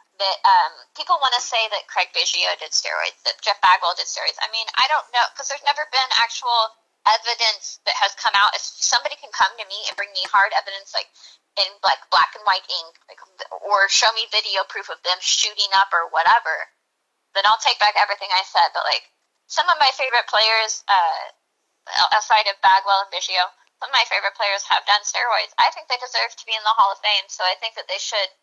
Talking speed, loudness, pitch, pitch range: 225 wpm, -19 LUFS, 215 Hz, 195-240 Hz